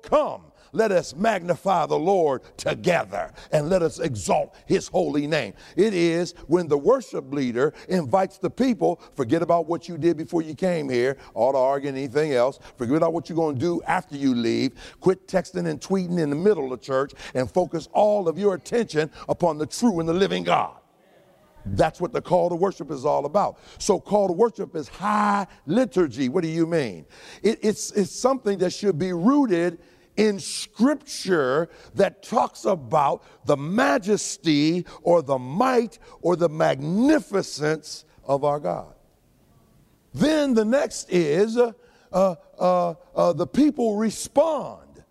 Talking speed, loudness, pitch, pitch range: 165 wpm, -23 LUFS, 175 Hz, 155-205 Hz